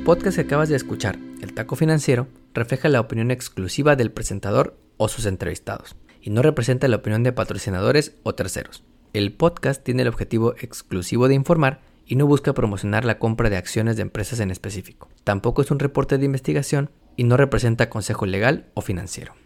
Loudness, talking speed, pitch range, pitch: -22 LUFS, 180 wpm, 105-140 Hz, 120 Hz